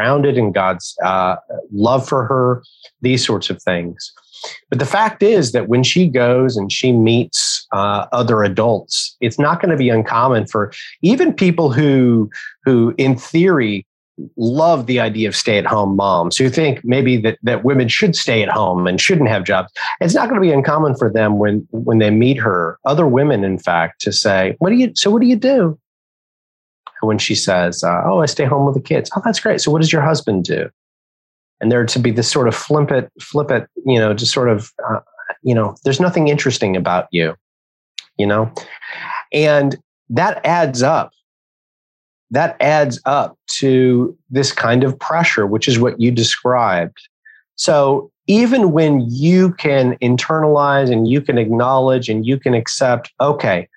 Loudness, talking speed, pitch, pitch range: -15 LUFS, 180 wpm, 125 Hz, 110-145 Hz